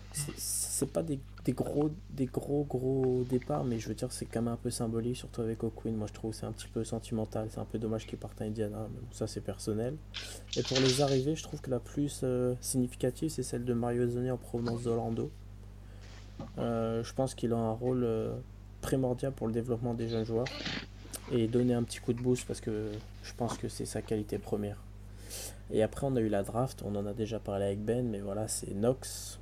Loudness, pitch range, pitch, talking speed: -34 LUFS, 105-125 Hz, 115 Hz, 230 wpm